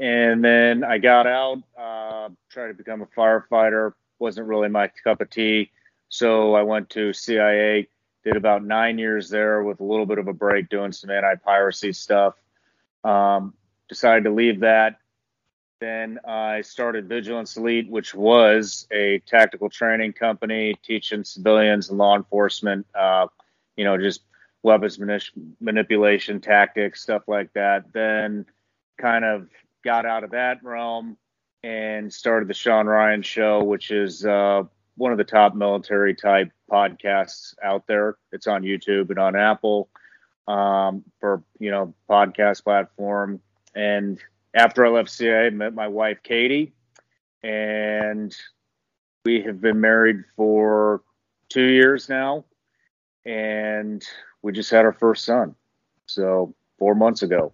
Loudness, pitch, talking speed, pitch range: -20 LUFS, 105 Hz, 145 wpm, 100-115 Hz